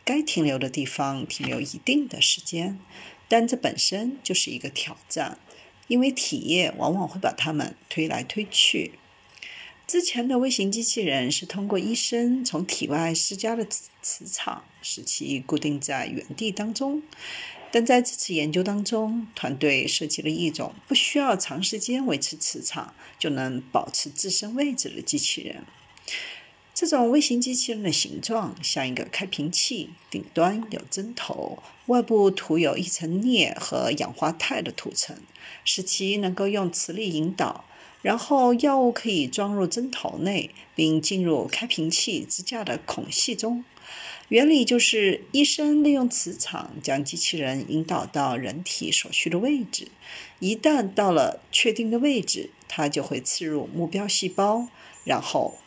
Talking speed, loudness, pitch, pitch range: 235 characters per minute, -24 LUFS, 205 Hz, 165-245 Hz